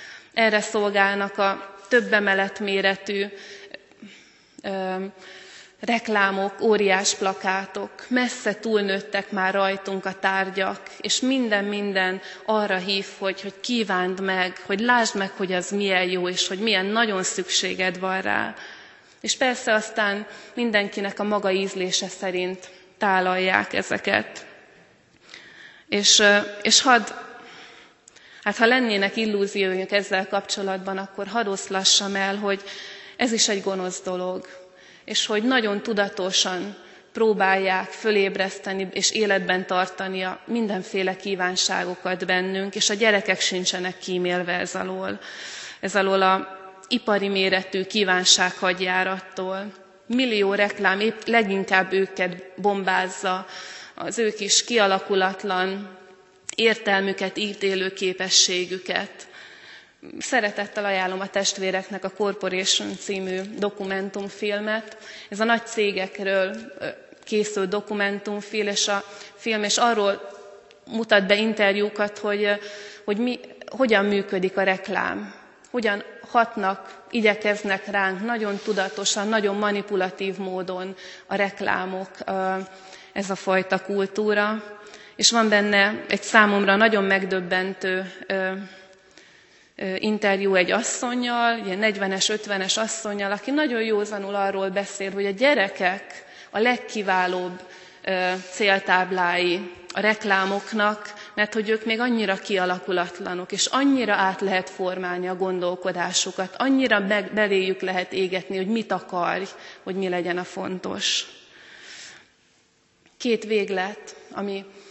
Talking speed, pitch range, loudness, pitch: 110 wpm, 190-210 Hz, -23 LUFS, 195 Hz